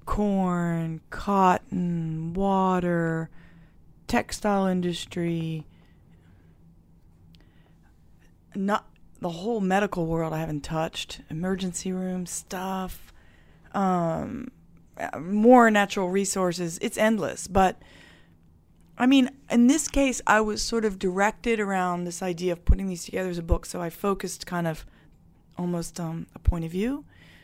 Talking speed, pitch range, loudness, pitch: 120 wpm, 160-200 Hz, -26 LUFS, 180 Hz